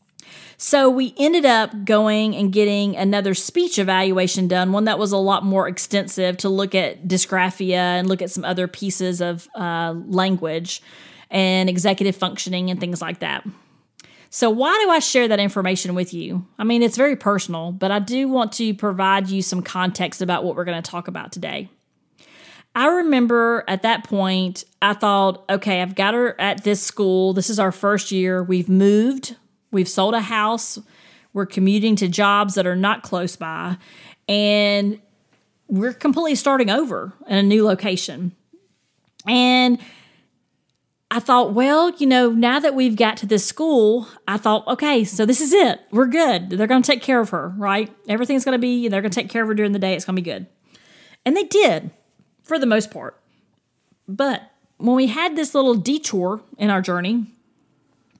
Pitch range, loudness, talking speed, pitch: 185-240 Hz, -19 LUFS, 185 wpm, 205 Hz